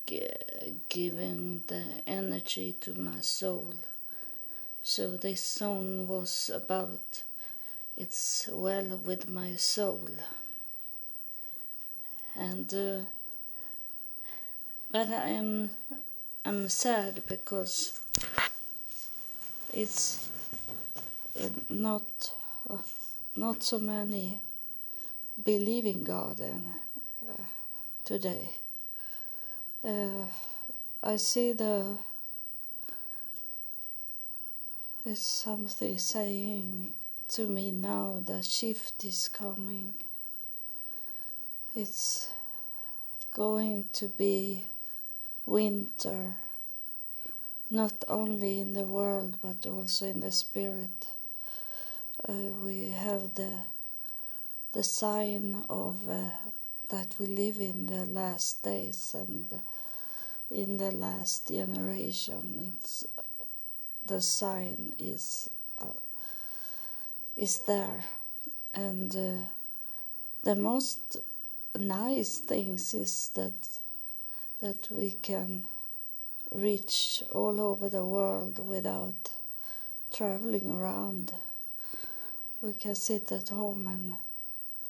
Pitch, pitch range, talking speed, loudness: 195 Hz, 180-210 Hz, 80 wpm, -33 LUFS